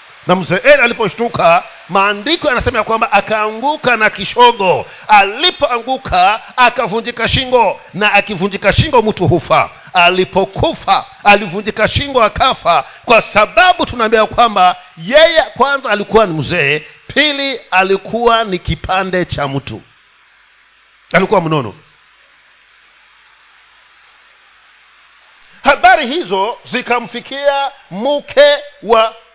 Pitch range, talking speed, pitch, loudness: 195-280 Hz, 90 wpm, 225 Hz, -12 LUFS